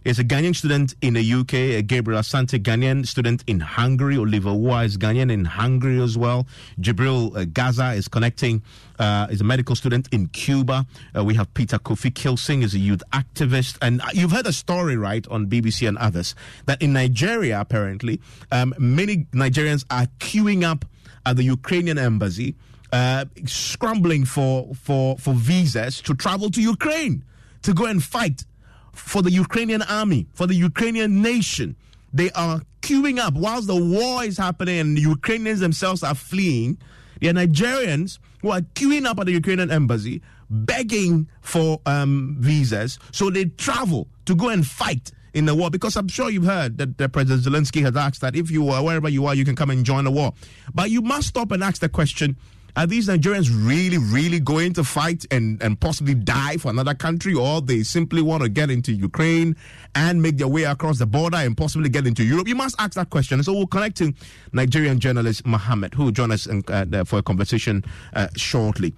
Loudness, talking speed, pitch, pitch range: -21 LUFS, 190 wpm, 135 Hz, 120-170 Hz